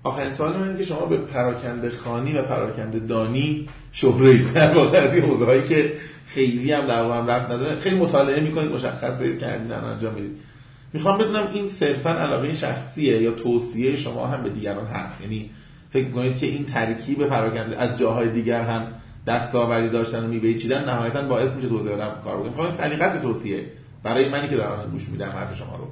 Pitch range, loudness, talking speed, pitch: 115-145 Hz, -22 LUFS, 185 wpm, 130 Hz